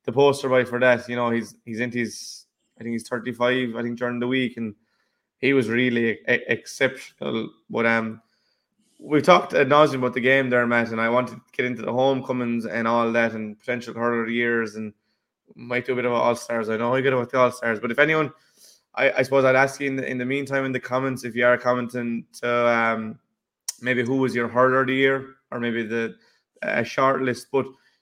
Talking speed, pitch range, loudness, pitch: 230 wpm, 115-130 Hz, -22 LUFS, 125 Hz